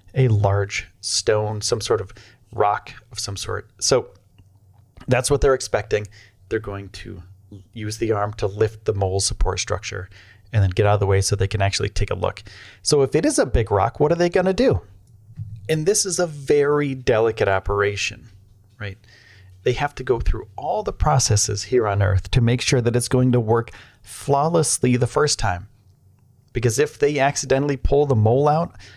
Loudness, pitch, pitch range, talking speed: -21 LUFS, 110 Hz, 100-130 Hz, 195 wpm